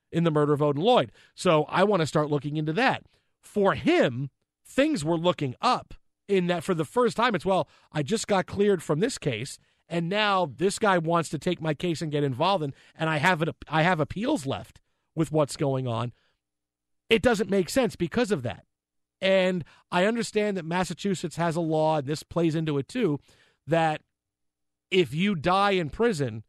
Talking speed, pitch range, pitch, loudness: 195 wpm, 150-195 Hz, 170 Hz, -26 LUFS